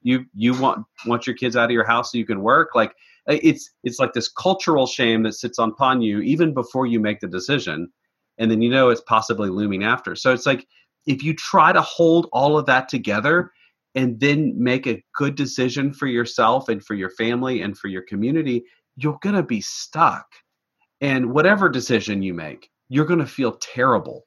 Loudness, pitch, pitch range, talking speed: -20 LUFS, 125 Hz, 115-145 Hz, 200 wpm